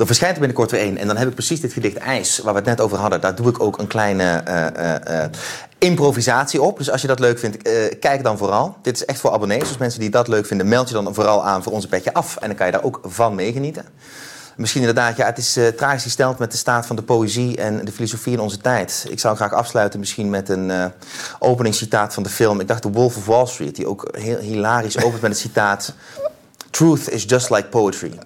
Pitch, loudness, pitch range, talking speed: 115 Hz, -19 LUFS, 105-125 Hz, 260 wpm